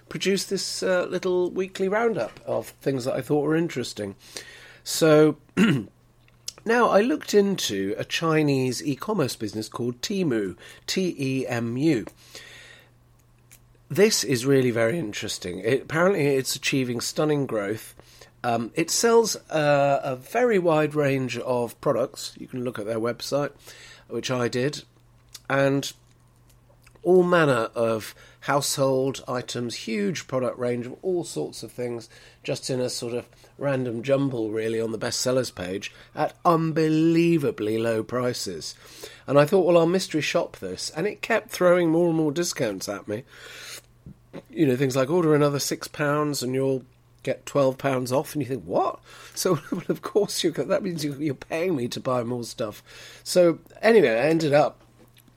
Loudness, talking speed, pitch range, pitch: -24 LUFS, 155 wpm, 120-160 Hz, 135 Hz